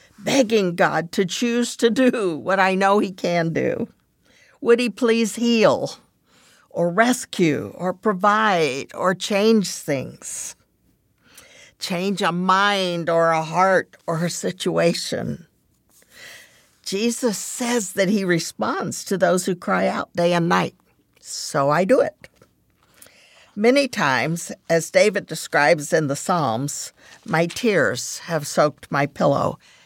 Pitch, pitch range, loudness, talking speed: 190 Hz, 170-225 Hz, -20 LUFS, 125 wpm